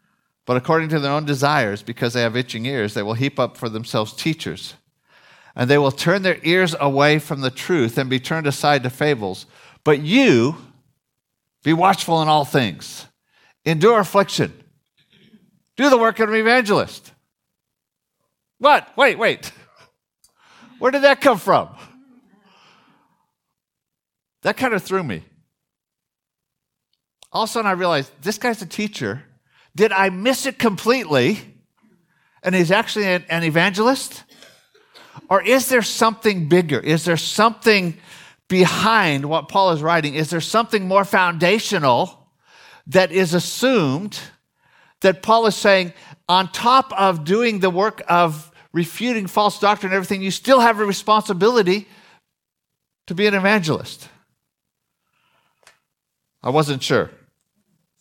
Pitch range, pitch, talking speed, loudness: 150-215 Hz, 185 Hz, 135 wpm, -18 LUFS